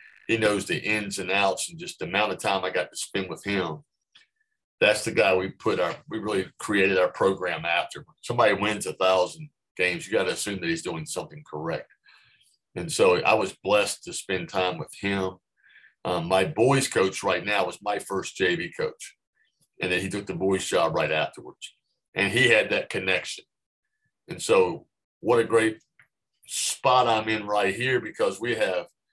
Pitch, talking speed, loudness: 110 Hz, 190 wpm, -25 LUFS